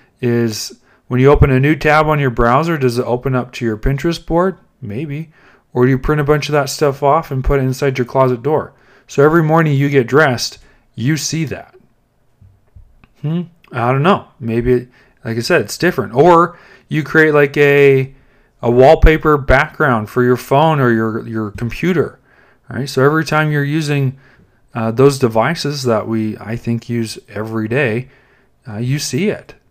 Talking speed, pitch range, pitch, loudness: 185 wpm, 120-150 Hz, 135 Hz, -14 LUFS